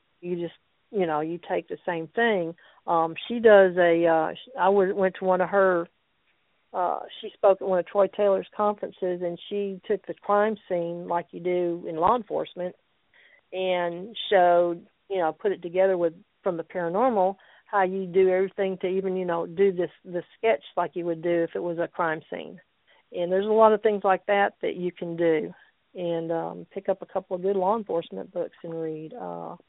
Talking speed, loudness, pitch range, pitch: 200 wpm, -25 LUFS, 170-195 Hz, 185 Hz